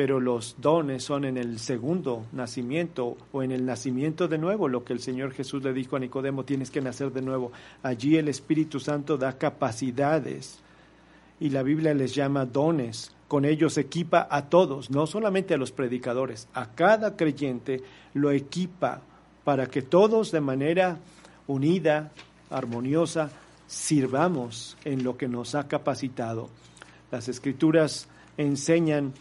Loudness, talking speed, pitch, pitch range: -27 LUFS, 150 wpm, 140 Hz, 130-155 Hz